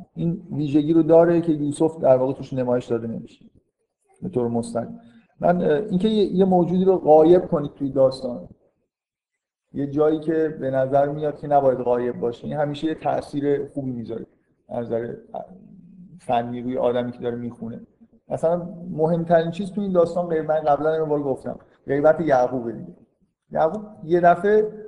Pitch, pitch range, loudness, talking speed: 155 Hz, 130-180 Hz, -21 LUFS, 155 wpm